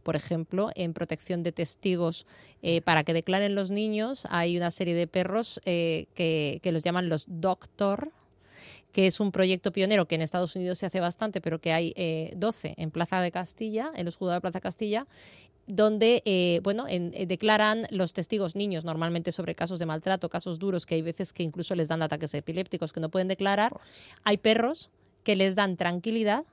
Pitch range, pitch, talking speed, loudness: 170-205 Hz, 180 Hz, 195 wpm, -28 LUFS